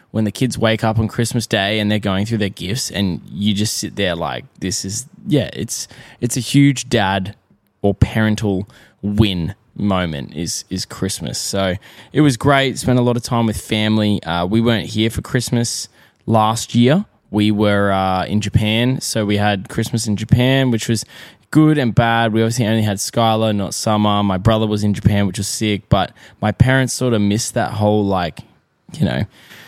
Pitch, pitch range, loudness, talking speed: 110 Hz, 100-120 Hz, -17 LUFS, 195 wpm